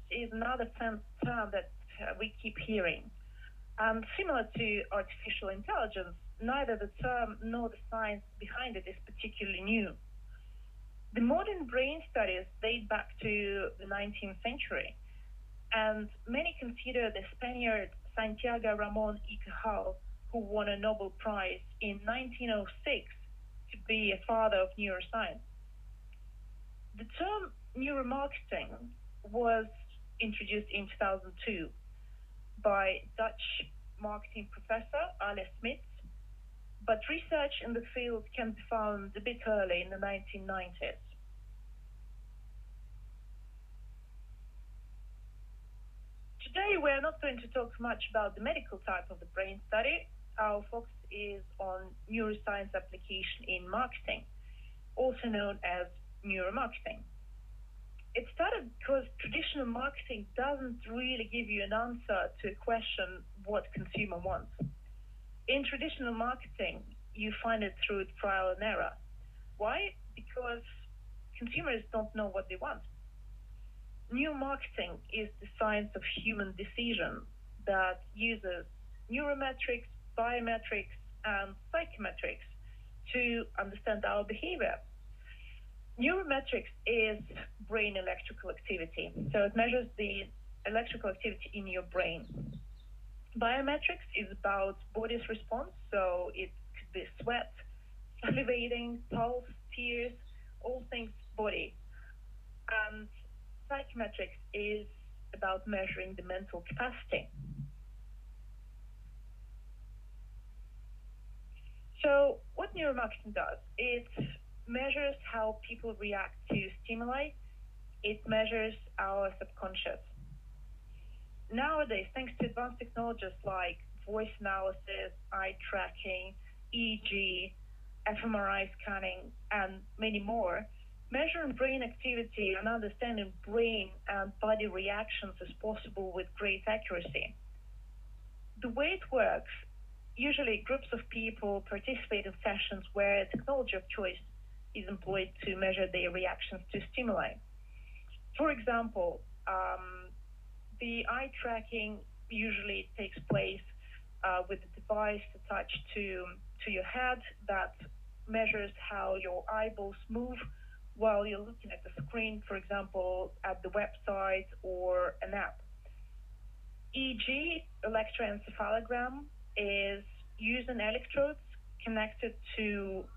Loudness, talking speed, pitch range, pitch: -36 LUFS, 110 wpm, 195-235 Hz, 215 Hz